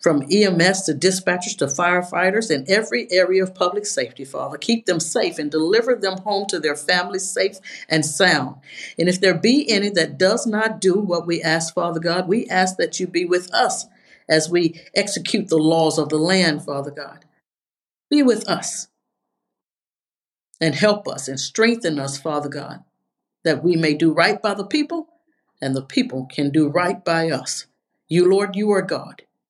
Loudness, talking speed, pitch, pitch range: -19 LUFS, 180 wpm, 180 Hz, 160-205 Hz